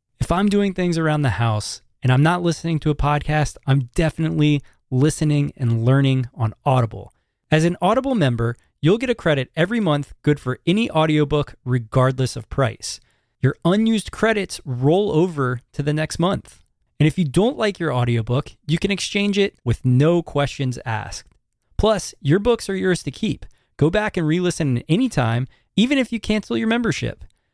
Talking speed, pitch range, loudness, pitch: 180 wpm, 130-180 Hz, -20 LUFS, 150 Hz